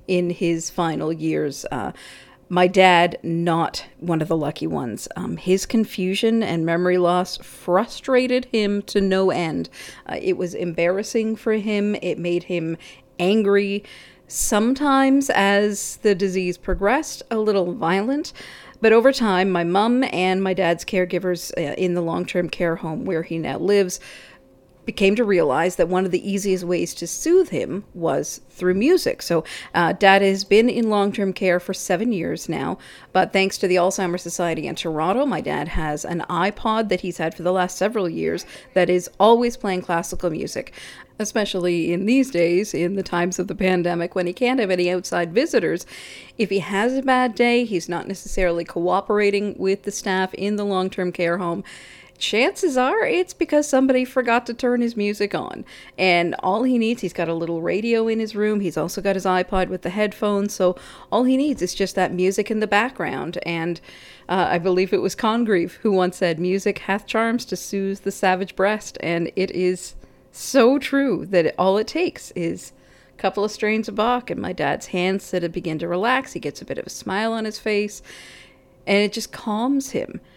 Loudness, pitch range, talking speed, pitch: -21 LUFS, 175-215 Hz, 190 wpm, 190 Hz